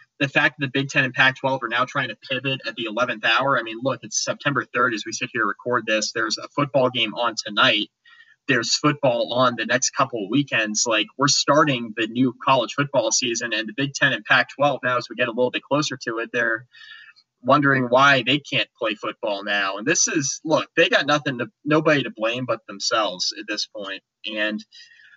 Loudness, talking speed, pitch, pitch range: -21 LUFS, 220 wpm, 130 Hz, 115-140 Hz